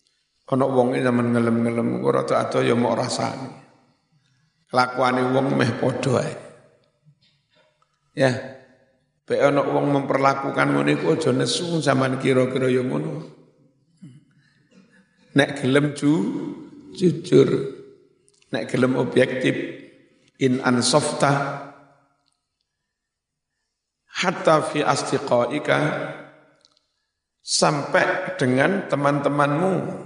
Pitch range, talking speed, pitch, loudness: 130-155 Hz, 90 wpm, 140 Hz, -21 LUFS